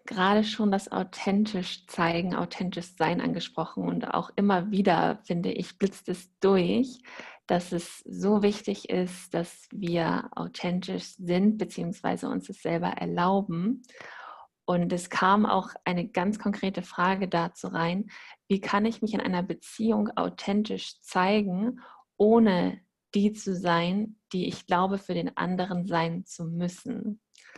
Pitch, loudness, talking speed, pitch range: 190 Hz, -28 LUFS, 135 wpm, 180-210 Hz